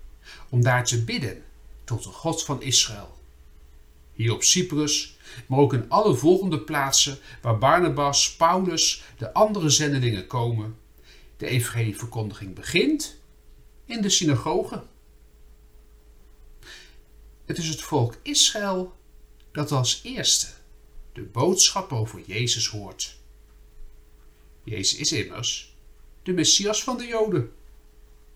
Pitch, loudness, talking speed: 115 Hz, -23 LUFS, 110 wpm